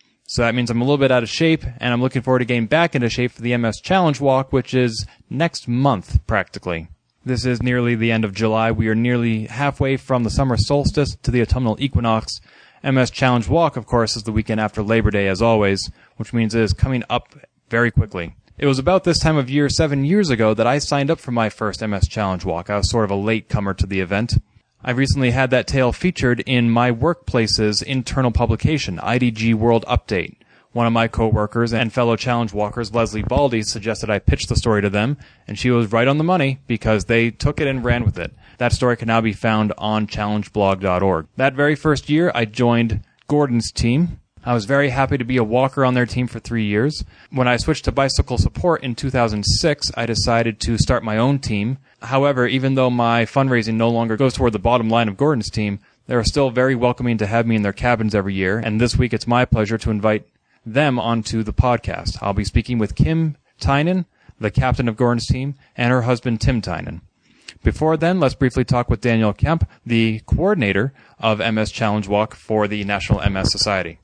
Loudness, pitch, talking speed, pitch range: -19 LUFS, 120 Hz, 215 wpm, 110-130 Hz